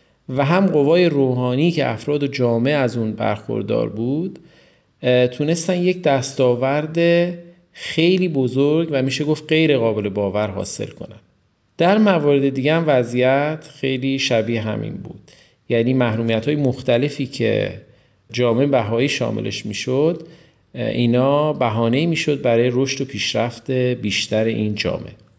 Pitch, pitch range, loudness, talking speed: 130 Hz, 115-150 Hz, -19 LUFS, 125 wpm